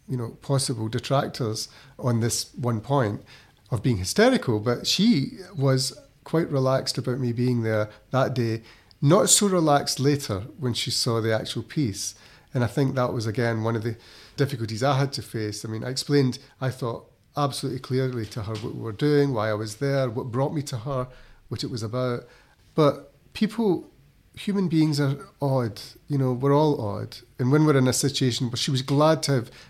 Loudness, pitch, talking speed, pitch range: -25 LUFS, 130 Hz, 195 wpm, 115-140 Hz